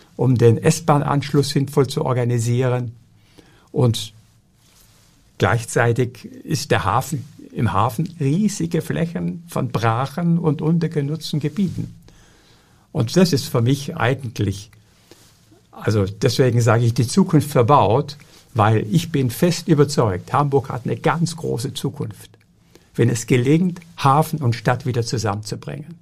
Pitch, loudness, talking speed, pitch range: 135 Hz, -19 LUFS, 120 wpm, 120-155 Hz